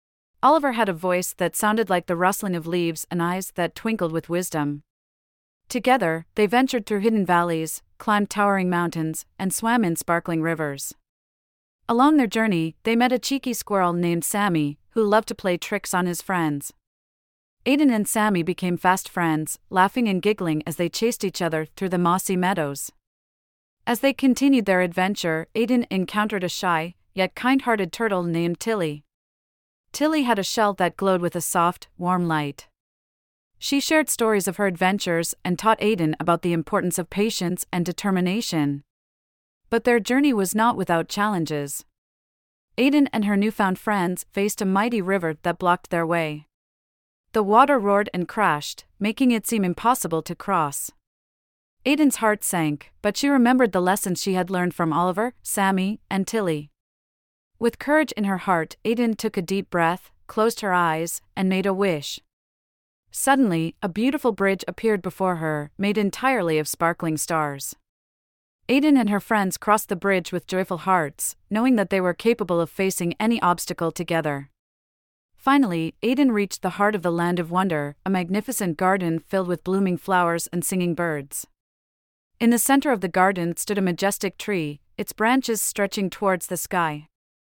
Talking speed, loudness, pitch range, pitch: 165 wpm, -23 LUFS, 165-215 Hz, 185 Hz